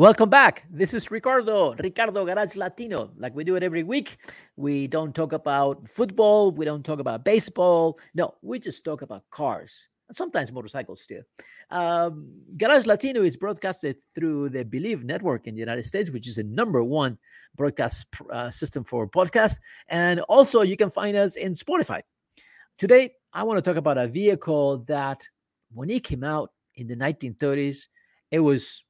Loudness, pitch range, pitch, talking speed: -24 LUFS, 140-205 Hz, 165 Hz, 175 wpm